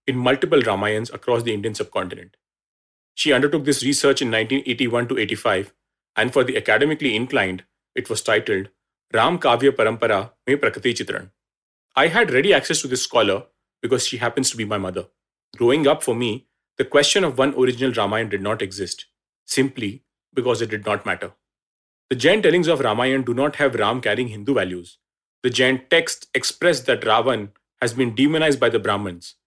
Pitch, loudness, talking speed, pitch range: 125 Hz, -20 LUFS, 175 wpm, 105-135 Hz